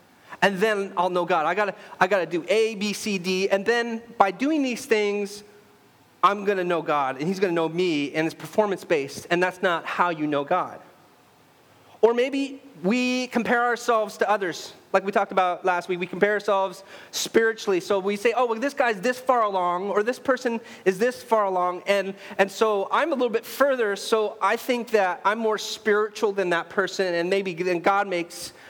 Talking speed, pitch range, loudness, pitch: 205 wpm, 180-225 Hz, -24 LUFS, 200 Hz